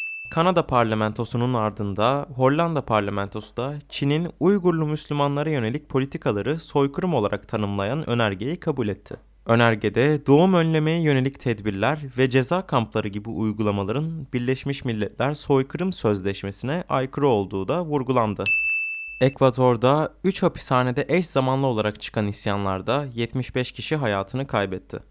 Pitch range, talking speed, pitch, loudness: 110-150 Hz, 110 wpm, 130 Hz, -23 LUFS